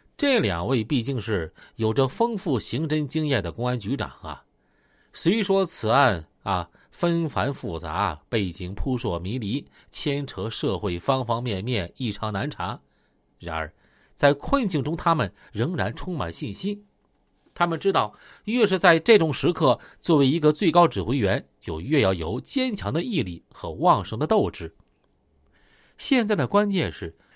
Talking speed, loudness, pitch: 225 characters per minute, -24 LUFS, 130 Hz